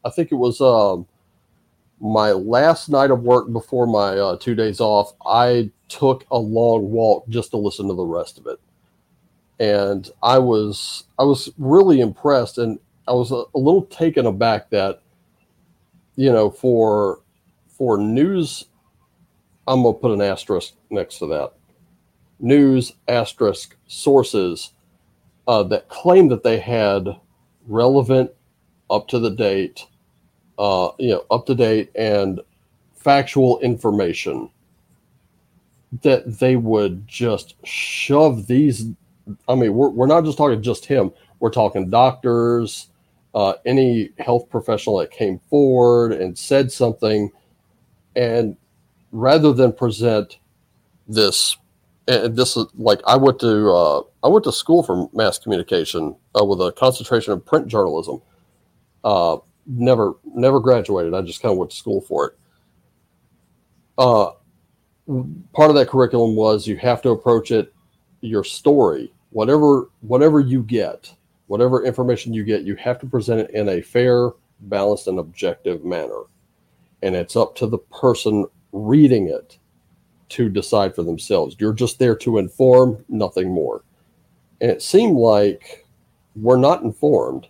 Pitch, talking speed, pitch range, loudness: 120 Hz, 140 wpm, 105-130 Hz, -18 LUFS